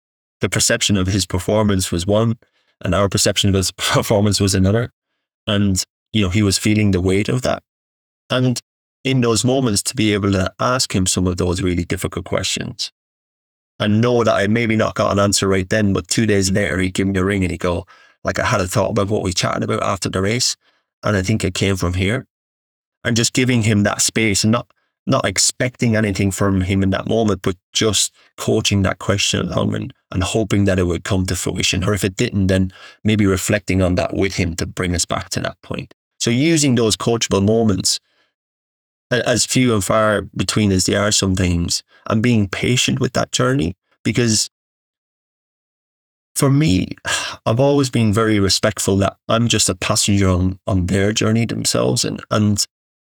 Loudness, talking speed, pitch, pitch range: -17 LUFS, 195 wpm, 100 Hz, 95-110 Hz